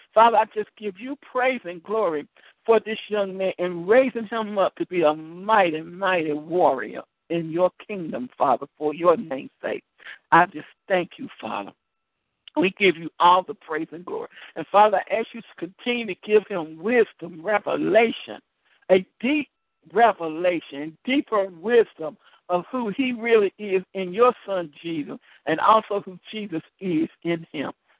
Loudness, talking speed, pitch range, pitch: -23 LUFS, 165 wpm, 170-225 Hz, 190 Hz